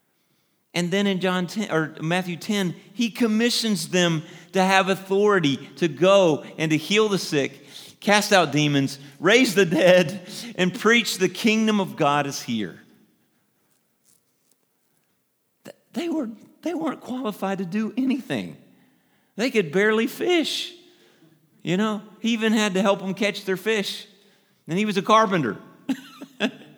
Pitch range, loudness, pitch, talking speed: 180-220 Hz, -22 LUFS, 200 Hz, 140 wpm